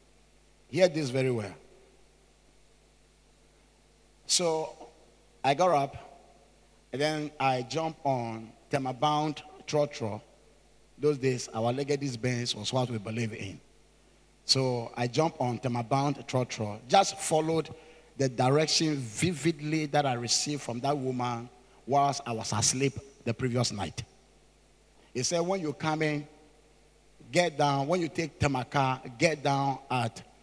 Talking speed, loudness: 125 wpm, -29 LUFS